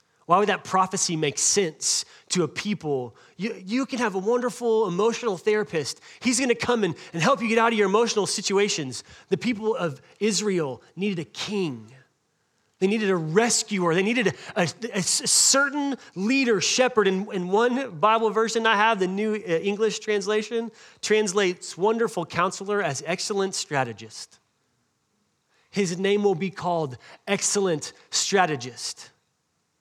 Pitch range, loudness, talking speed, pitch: 175-225 Hz, -24 LUFS, 145 wpm, 200 Hz